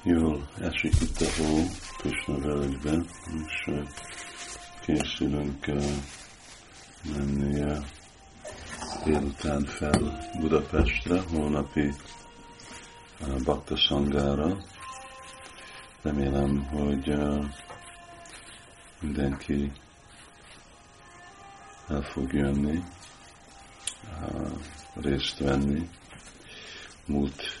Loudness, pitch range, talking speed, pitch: -29 LUFS, 70-80 Hz, 55 wpm, 75 Hz